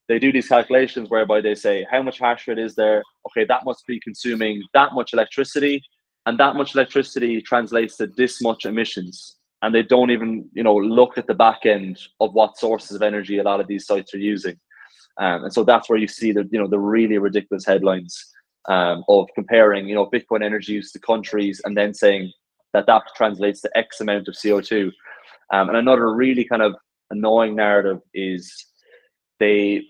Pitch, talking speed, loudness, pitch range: 110 Hz, 195 wpm, -19 LUFS, 100-120 Hz